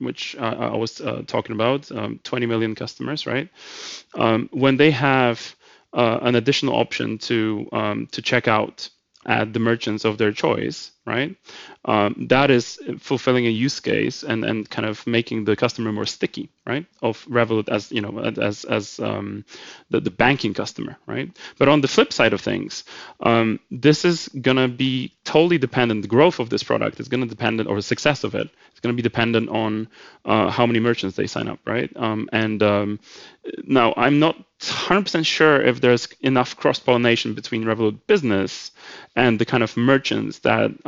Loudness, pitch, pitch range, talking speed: -21 LUFS, 120 Hz, 110-130 Hz, 185 wpm